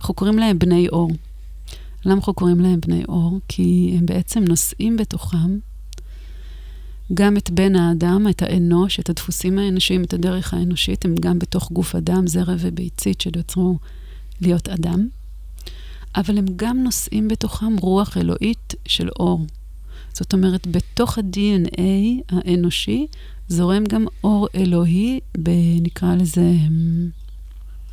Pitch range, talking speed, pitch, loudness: 165-190 Hz, 125 wpm, 175 Hz, -19 LUFS